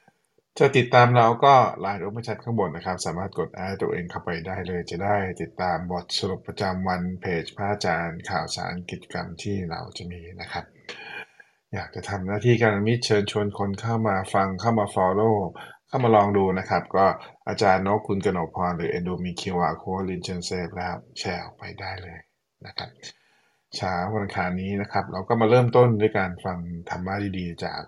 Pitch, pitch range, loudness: 95 Hz, 90-105 Hz, -24 LUFS